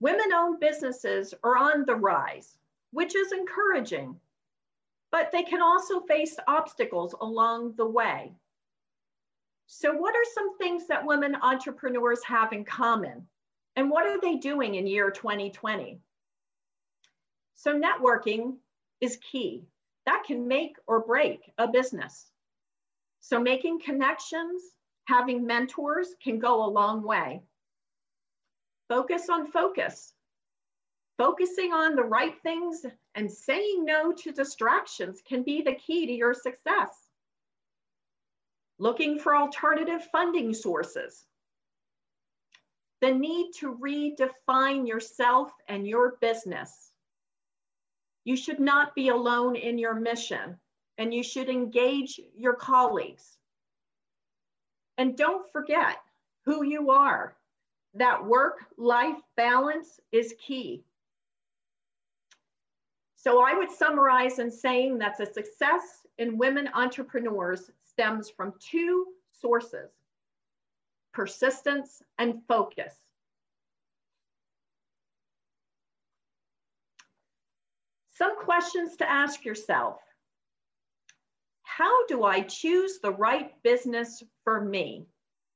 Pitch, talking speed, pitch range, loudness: 260 Hz, 105 wpm, 235-325 Hz, -27 LUFS